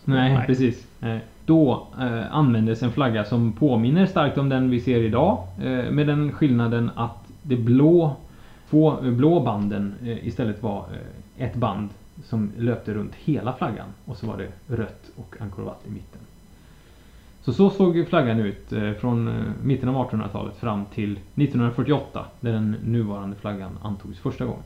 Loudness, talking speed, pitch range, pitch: -23 LUFS, 145 wpm, 105-130 Hz, 115 Hz